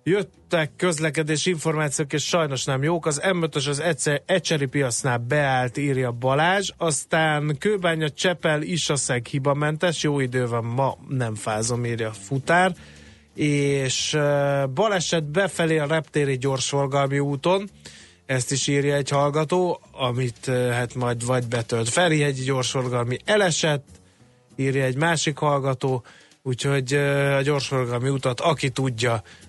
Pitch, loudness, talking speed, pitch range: 140 Hz, -23 LUFS, 130 wpm, 130-160 Hz